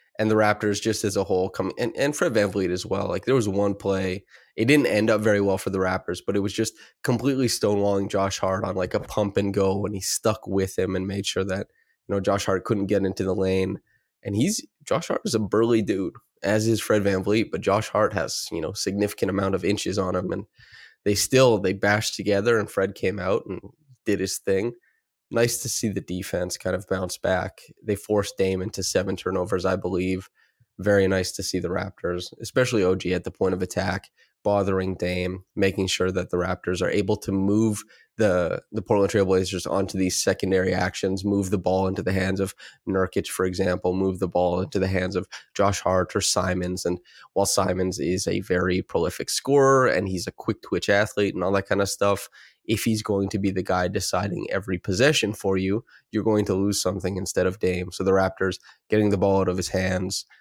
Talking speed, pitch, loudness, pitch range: 220 wpm, 95 Hz, -24 LUFS, 95-105 Hz